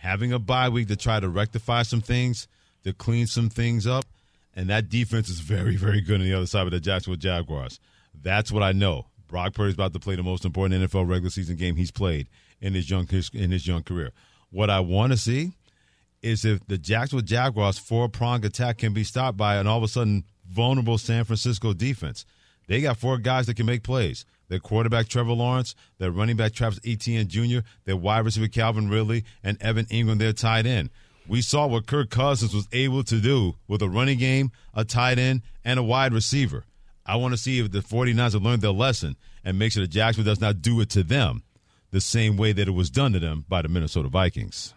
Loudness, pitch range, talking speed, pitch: -25 LUFS, 95-120 Hz, 220 wpm, 110 Hz